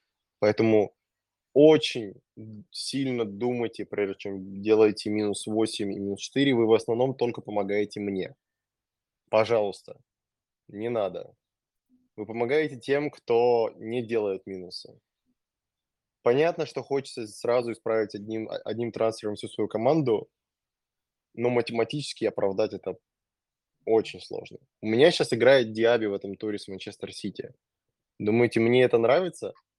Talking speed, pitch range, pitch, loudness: 120 wpm, 105-125 Hz, 115 Hz, -26 LUFS